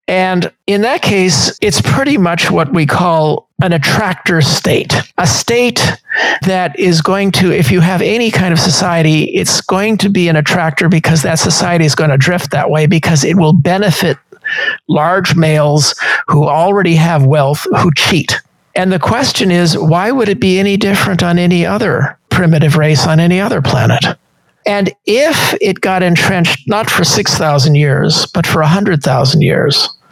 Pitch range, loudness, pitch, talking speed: 155-190 Hz, -11 LUFS, 175 Hz, 170 wpm